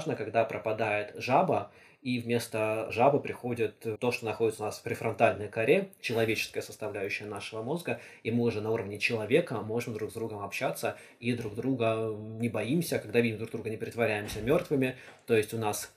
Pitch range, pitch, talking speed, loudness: 110-120 Hz, 115 Hz, 175 wpm, -31 LUFS